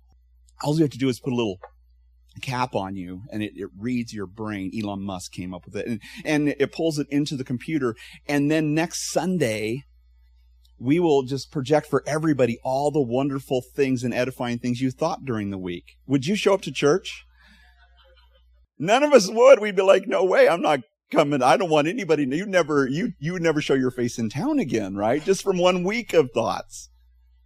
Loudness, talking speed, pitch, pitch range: -23 LUFS, 210 wpm, 130 Hz, 95-155 Hz